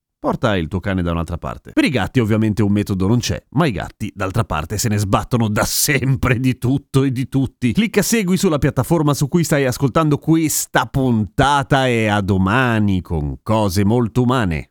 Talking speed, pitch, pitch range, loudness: 190 wpm, 120 Hz, 100-135 Hz, -17 LUFS